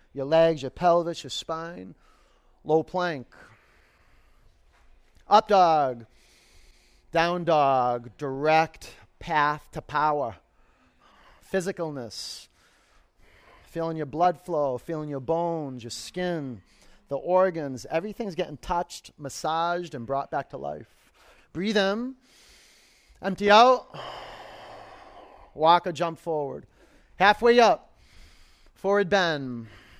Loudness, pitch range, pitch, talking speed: -25 LUFS, 130-180 Hz, 160 Hz, 100 wpm